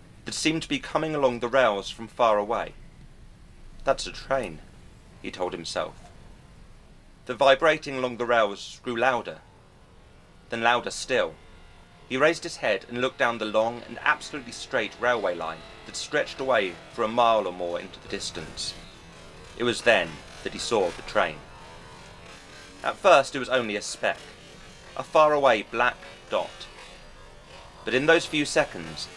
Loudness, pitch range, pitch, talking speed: -25 LUFS, 105-145 Hz, 125 Hz, 155 wpm